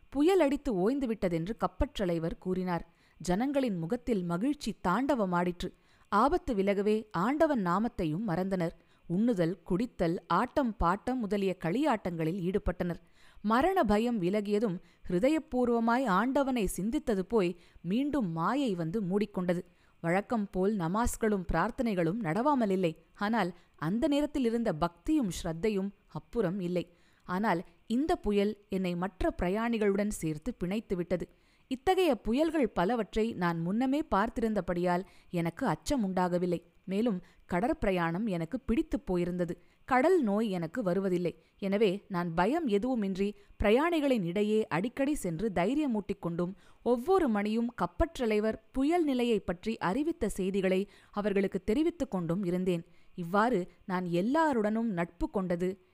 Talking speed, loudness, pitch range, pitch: 105 wpm, -31 LUFS, 180-240 Hz, 205 Hz